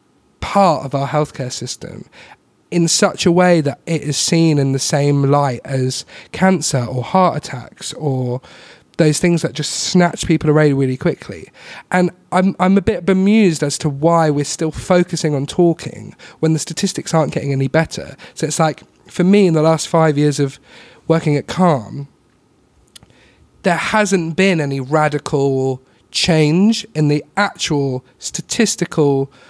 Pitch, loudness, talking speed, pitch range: 155 Hz, -16 LUFS, 155 wpm, 140-175 Hz